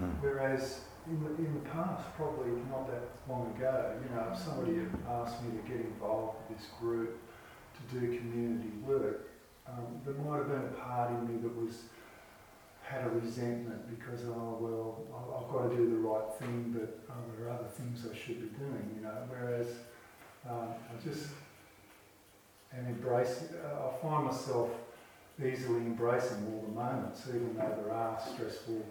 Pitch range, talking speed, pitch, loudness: 115-130 Hz, 175 wpm, 120 Hz, -38 LUFS